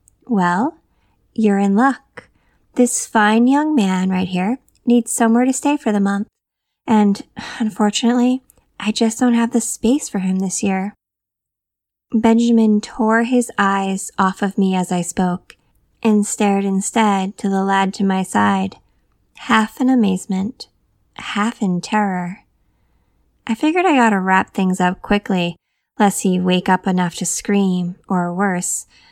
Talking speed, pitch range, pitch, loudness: 150 wpm, 190-230 Hz, 205 Hz, -17 LUFS